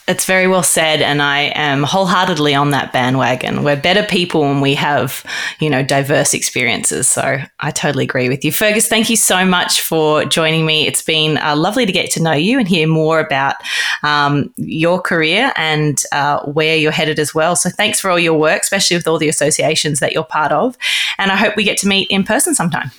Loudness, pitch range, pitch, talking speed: -13 LUFS, 150-185 Hz, 160 Hz, 215 wpm